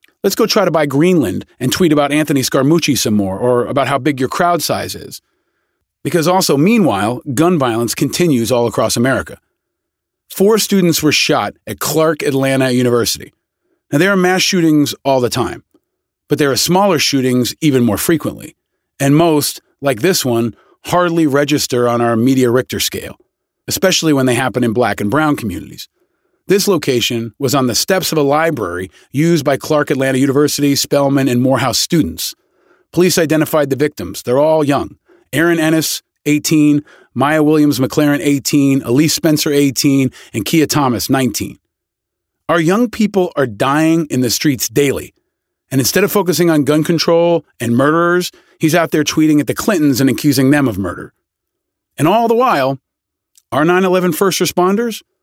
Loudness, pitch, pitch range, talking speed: -14 LUFS, 145 Hz, 130-165 Hz, 165 wpm